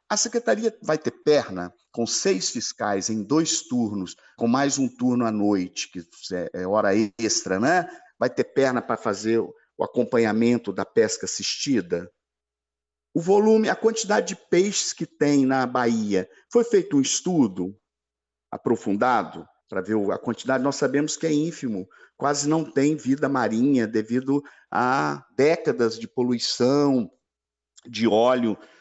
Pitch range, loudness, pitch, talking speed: 105-150 Hz, -23 LUFS, 120 Hz, 140 wpm